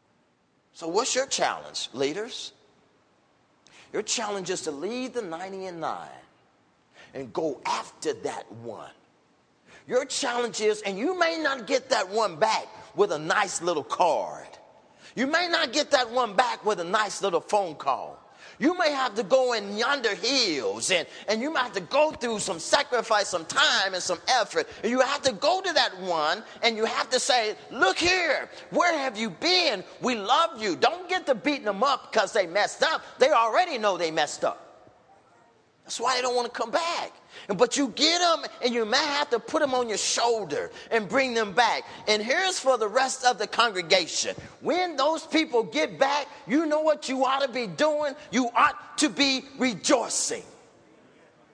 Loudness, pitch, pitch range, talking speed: -25 LUFS, 255 Hz, 220-305 Hz, 185 wpm